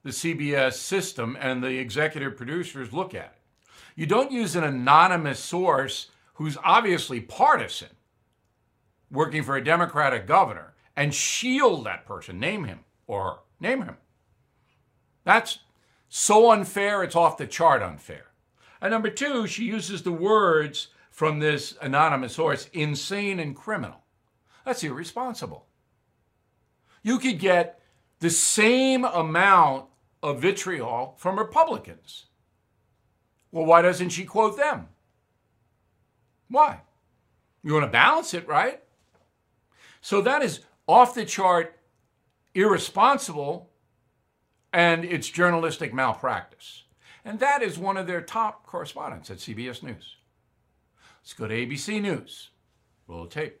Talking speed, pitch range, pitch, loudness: 125 wpm, 135-200 Hz, 165 Hz, -23 LUFS